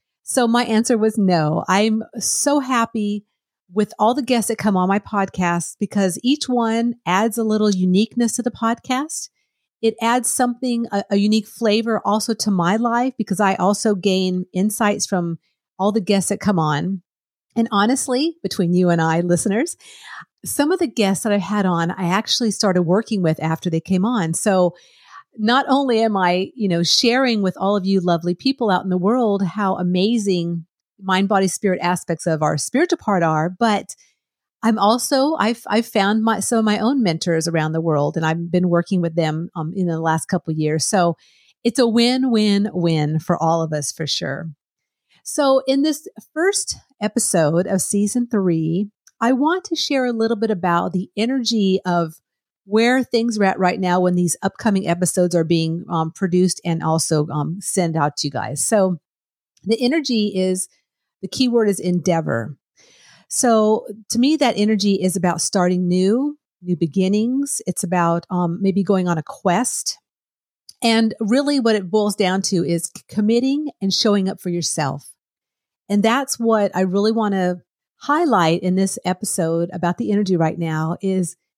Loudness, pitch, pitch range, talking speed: -19 LUFS, 200 Hz, 175-225 Hz, 180 wpm